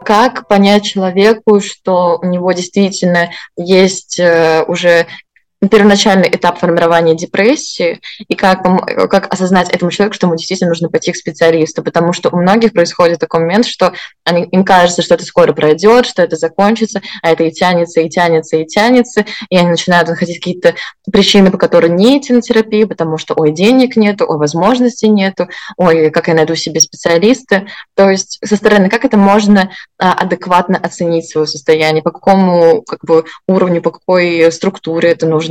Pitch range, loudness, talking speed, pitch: 170-205 Hz, -11 LUFS, 165 wpm, 180 Hz